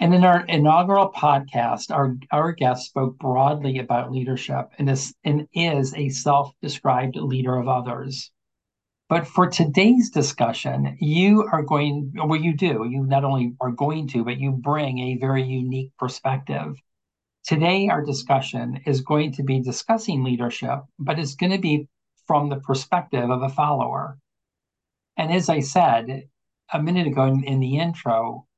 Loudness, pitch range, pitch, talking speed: -22 LUFS, 130-155 Hz, 140 Hz, 155 wpm